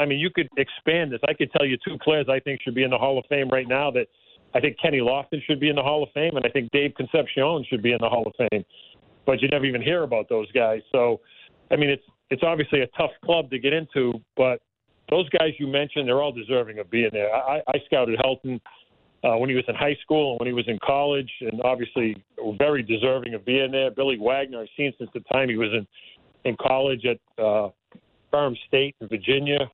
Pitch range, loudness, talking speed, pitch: 120-145 Hz, -24 LUFS, 245 wpm, 135 Hz